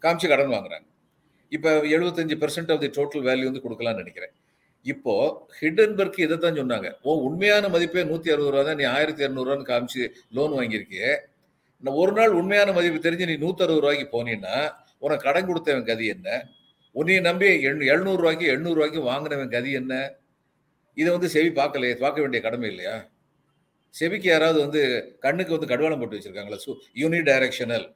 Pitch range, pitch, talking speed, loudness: 135-170 Hz, 150 Hz, 150 wpm, -23 LUFS